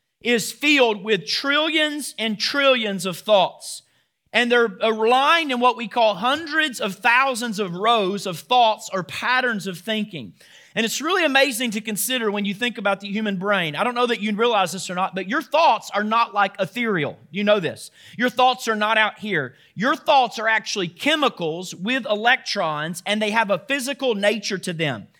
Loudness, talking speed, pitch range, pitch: -20 LUFS, 190 wpm, 200-250 Hz, 220 Hz